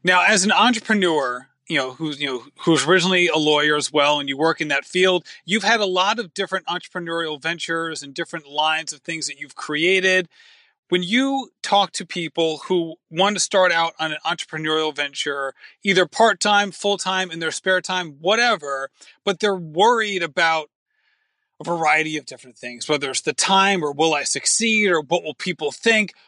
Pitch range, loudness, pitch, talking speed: 155-195 Hz, -20 LUFS, 170 Hz, 190 wpm